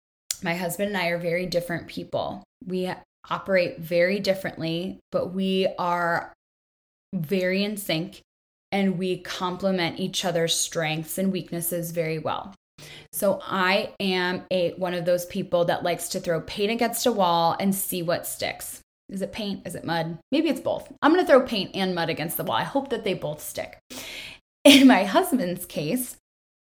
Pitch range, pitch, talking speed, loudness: 170-195 Hz, 185 Hz, 175 wpm, -25 LUFS